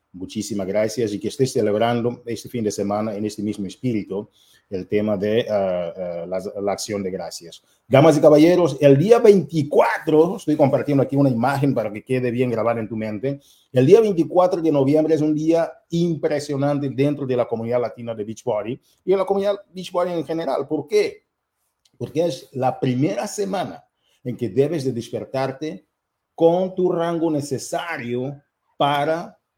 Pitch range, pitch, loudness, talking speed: 115-160 Hz, 135 Hz, -20 LUFS, 170 wpm